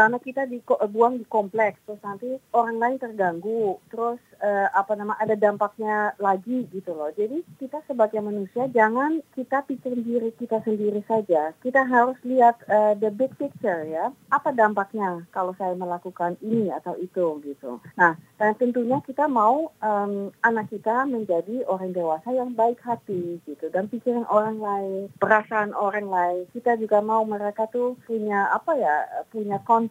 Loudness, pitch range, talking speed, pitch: -24 LUFS, 195-240 Hz, 160 wpm, 215 Hz